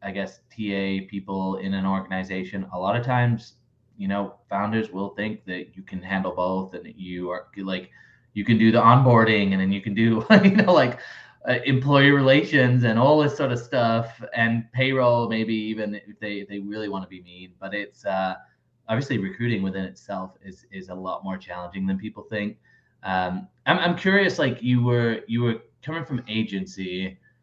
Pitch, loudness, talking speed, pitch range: 105 Hz, -23 LUFS, 195 wpm, 95-120 Hz